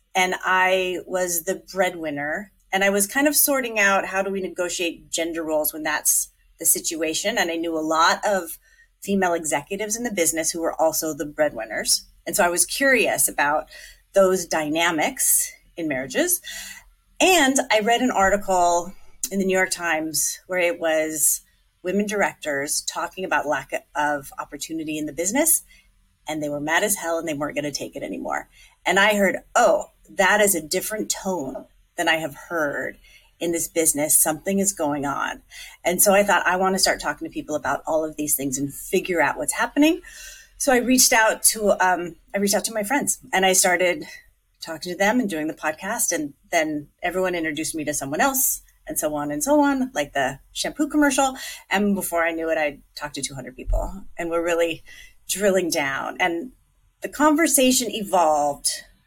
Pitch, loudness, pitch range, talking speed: 180 Hz, -21 LUFS, 155-215 Hz, 190 wpm